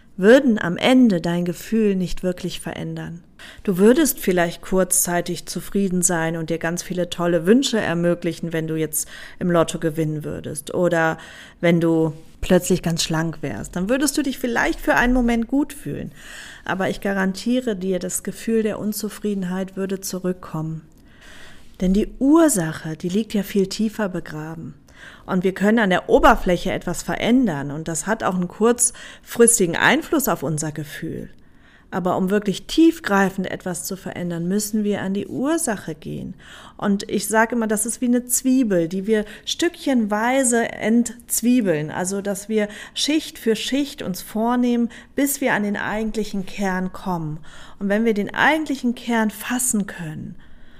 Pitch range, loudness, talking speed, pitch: 175-230 Hz, -21 LUFS, 155 wpm, 195 Hz